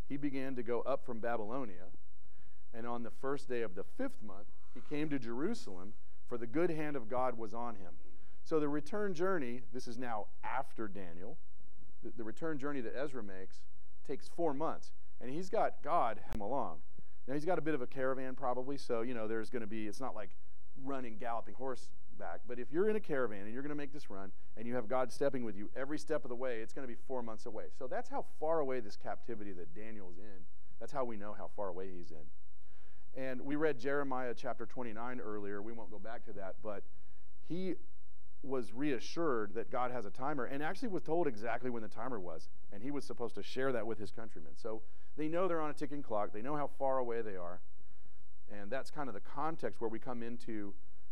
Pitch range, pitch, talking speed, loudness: 100-135 Hz, 120 Hz, 225 wpm, -41 LUFS